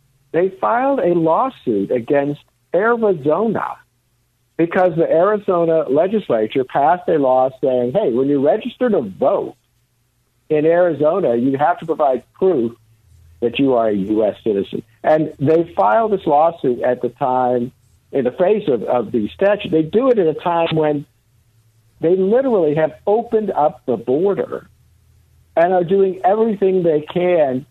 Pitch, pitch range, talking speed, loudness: 155 Hz, 125-190 Hz, 145 wpm, -17 LUFS